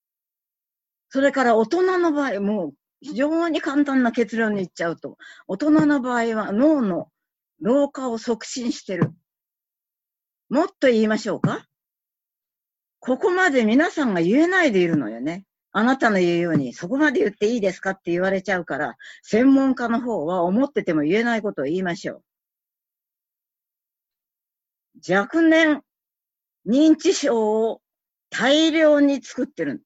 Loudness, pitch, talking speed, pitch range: -21 LUFS, 235 Hz, 275 characters per minute, 195-290 Hz